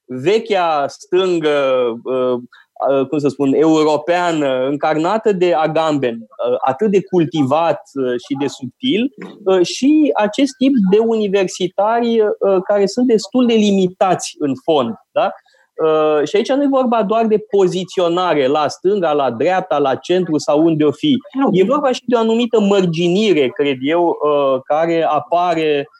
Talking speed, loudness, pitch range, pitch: 130 wpm, -16 LUFS, 150-215 Hz, 180 Hz